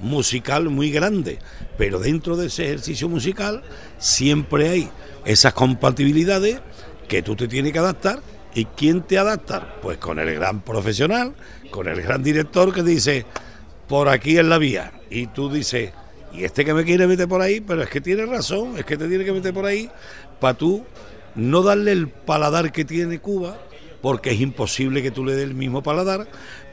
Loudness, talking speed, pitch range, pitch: -20 LUFS, 185 wpm, 130-180 Hz, 150 Hz